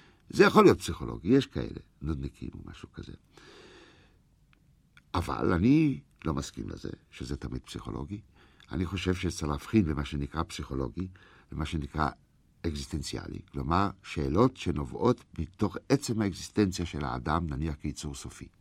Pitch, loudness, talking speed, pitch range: 80 Hz, -30 LUFS, 125 wpm, 70-95 Hz